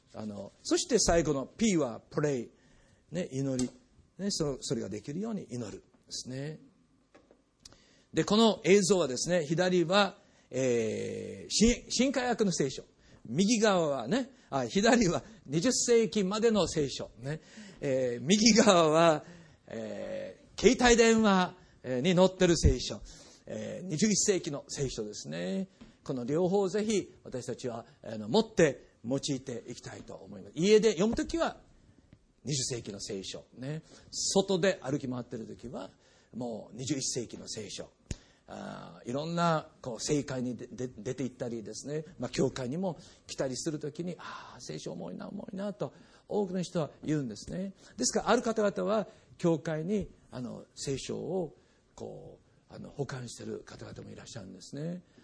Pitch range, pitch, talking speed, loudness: 130-205 Hz, 165 Hz, 275 characters per minute, -30 LUFS